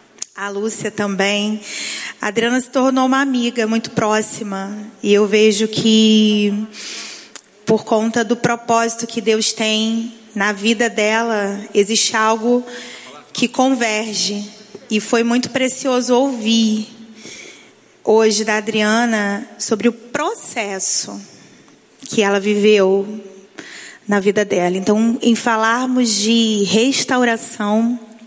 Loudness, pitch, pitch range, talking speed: -16 LUFS, 220 Hz, 210-235 Hz, 110 wpm